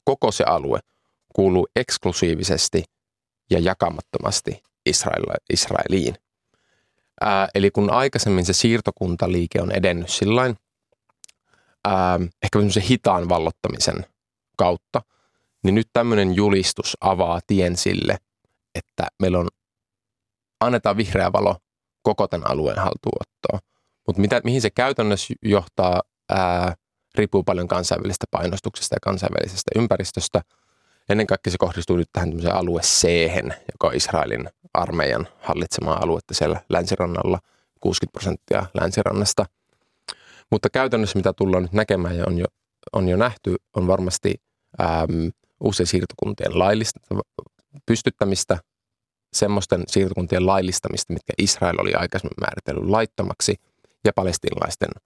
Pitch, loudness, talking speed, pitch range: 95 Hz, -22 LUFS, 110 wpm, 90-110 Hz